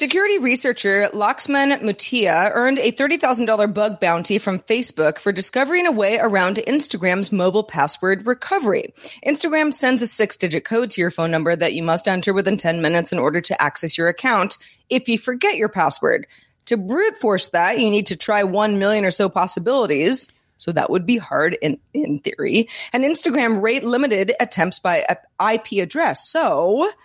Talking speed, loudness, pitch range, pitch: 175 wpm, -18 LUFS, 185-255 Hz, 215 Hz